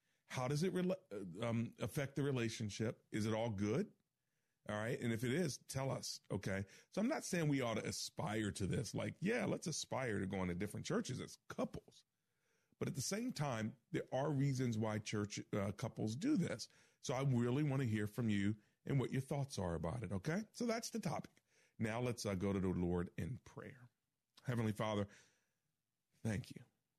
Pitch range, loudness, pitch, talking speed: 105-140 Hz, -42 LUFS, 120 Hz, 195 wpm